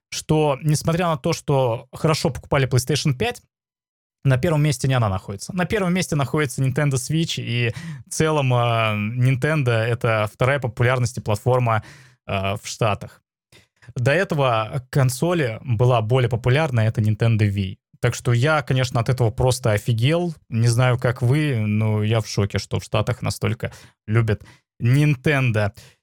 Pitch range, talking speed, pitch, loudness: 115-150 Hz, 150 wpm, 125 Hz, -21 LUFS